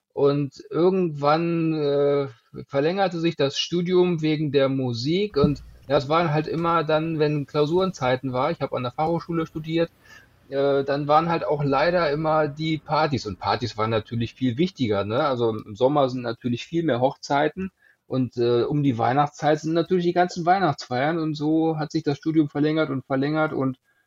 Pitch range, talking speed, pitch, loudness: 135-165 Hz, 170 wpm, 150 Hz, -23 LUFS